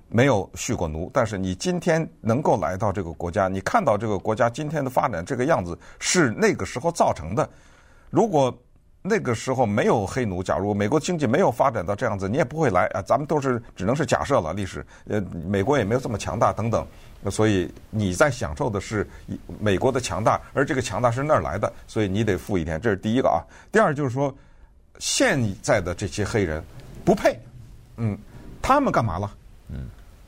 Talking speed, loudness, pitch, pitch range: 305 characters per minute, -23 LUFS, 105 Hz, 95-125 Hz